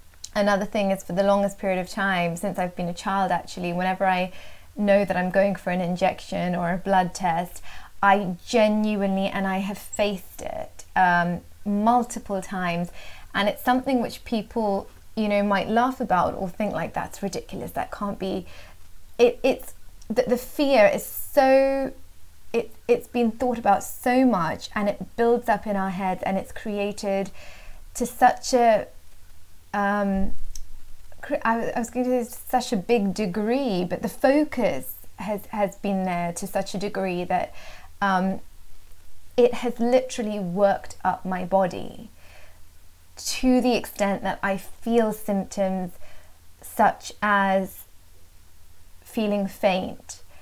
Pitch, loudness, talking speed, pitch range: 195 Hz, -24 LUFS, 150 wpm, 180-220 Hz